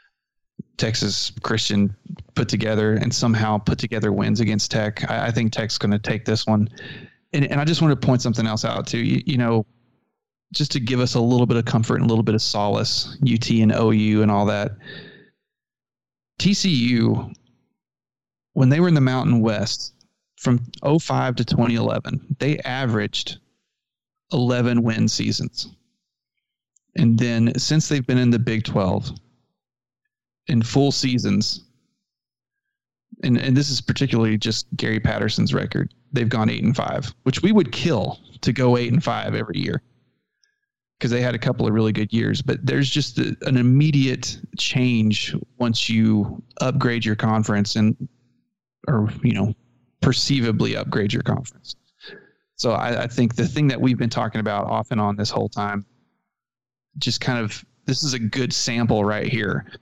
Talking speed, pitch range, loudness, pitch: 165 wpm, 110-130 Hz, -21 LUFS, 120 Hz